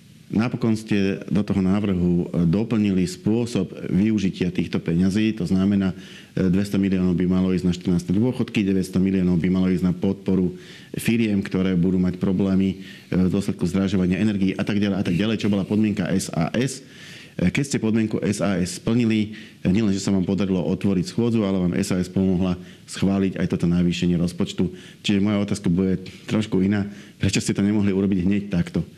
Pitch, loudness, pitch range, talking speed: 95 Hz, -22 LUFS, 90-105 Hz, 165 wpm